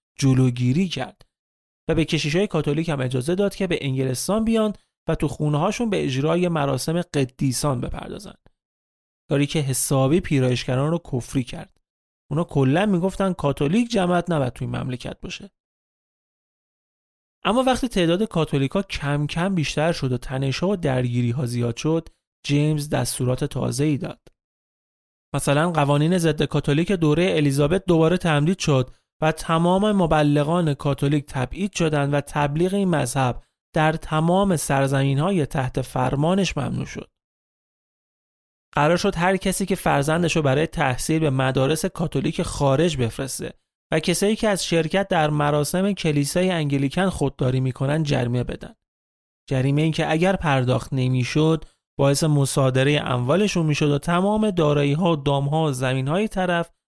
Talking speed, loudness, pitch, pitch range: 140 wpm, -22 LUFS, 150 Hz, 135-175 Hz